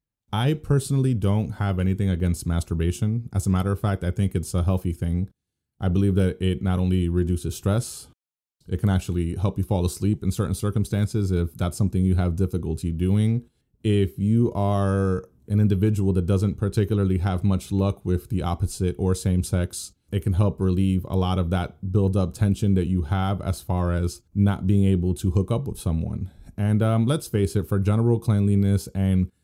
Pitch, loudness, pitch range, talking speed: 95 Hz, -24 LUFS, 90-105 Hz, 190 wpm